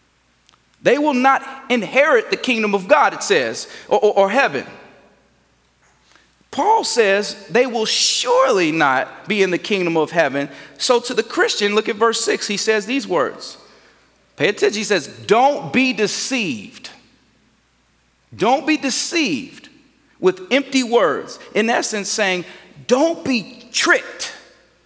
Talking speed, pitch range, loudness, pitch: 140 wpm, 210-285 Hz, -17 LUFS, 245 Hz